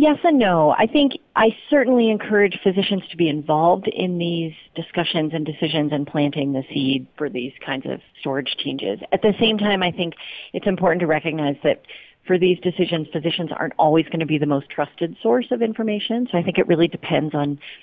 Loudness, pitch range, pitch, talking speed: -20 LUFS, 155-205 Hz, 170 Hz, 200 wpm